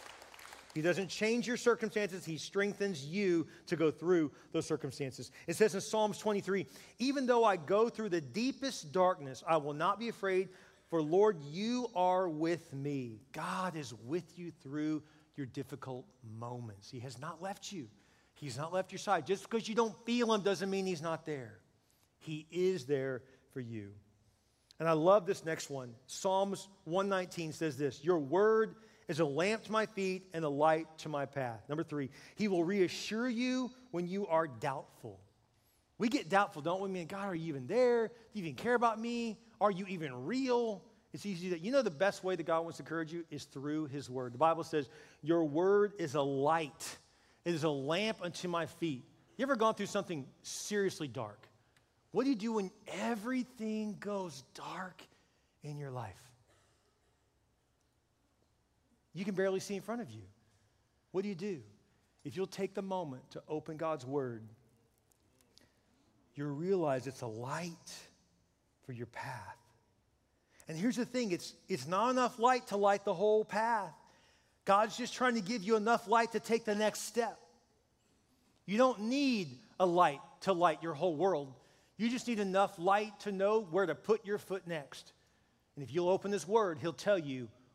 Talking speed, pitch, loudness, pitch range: 185 wpm, 175 Hz, -35 LUFS, 140-205 Hz